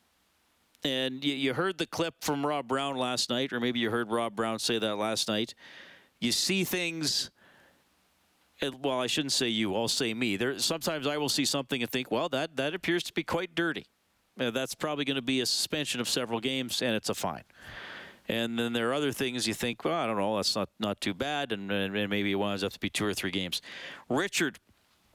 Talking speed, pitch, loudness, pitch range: 225 wpm, 125 Hz, -30 LUFS, 110-145 Hz